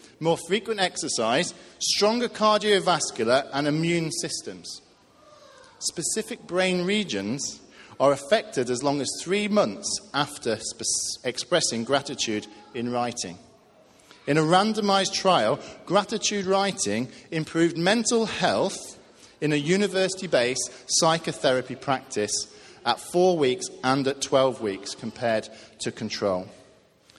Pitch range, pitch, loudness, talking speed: 125-195 Hz, 160 Hz, -25 LUFS, 105 wpm